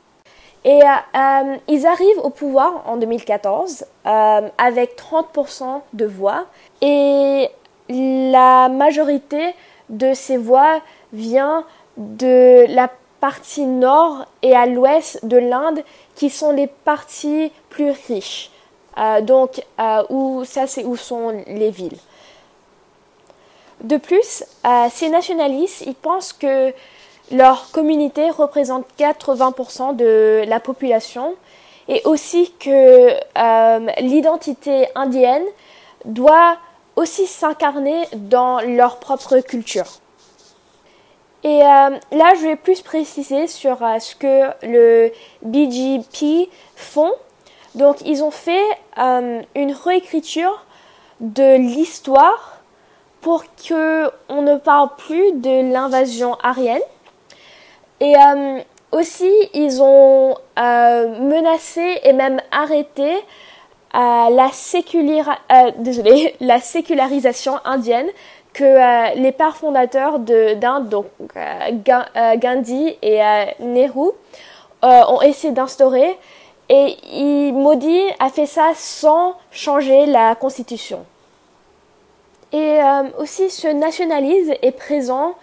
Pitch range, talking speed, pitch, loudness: 255-315 Hz, 110 wpm, 275 Hz, -15 LUFS